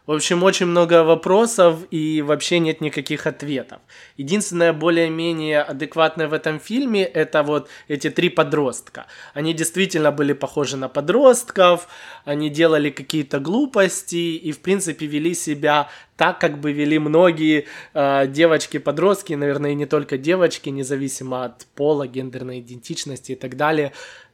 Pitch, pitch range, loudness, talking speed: 155 Hz, 145-170 Hz, -19 LUFS, 135 wpm